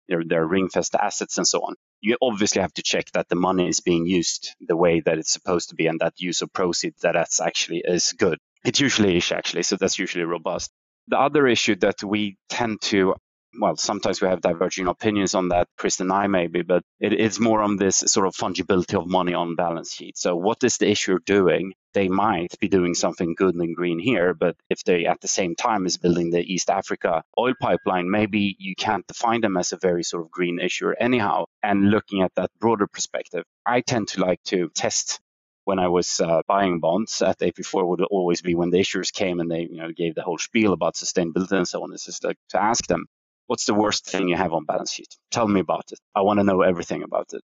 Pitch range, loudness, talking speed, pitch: 85-100 Hz, -22 LUFS, 230 wpm, 95 Hz